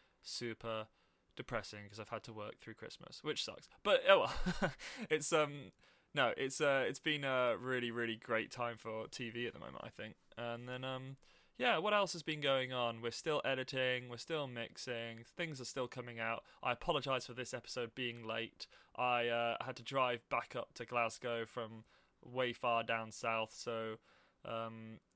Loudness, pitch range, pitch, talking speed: -39 LUFS, 115-130 Hz, 120 Hz, 185 wpm